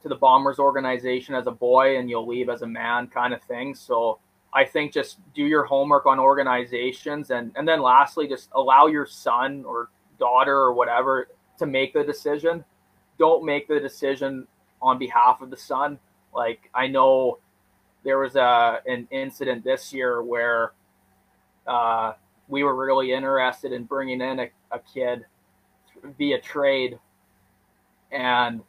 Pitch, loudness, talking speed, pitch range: 130 Hz, -22 LUFS, 155 wpm, 120-135 Hz